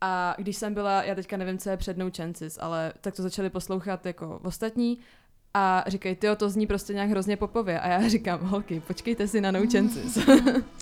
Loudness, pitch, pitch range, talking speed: -27 LUFS, 195 Hz, 185-210 Hz, 195 wpm